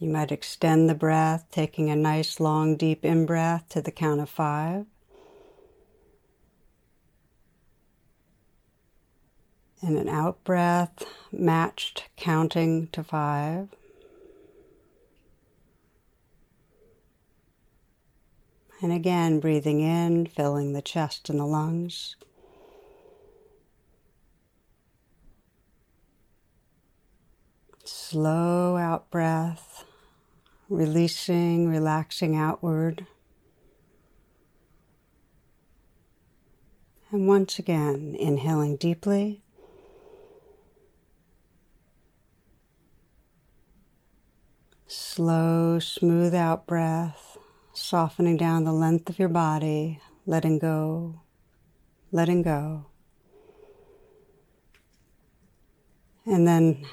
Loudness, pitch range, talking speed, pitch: -25 LUFS, 155-190 Hz, 65 wpm, 165 Hz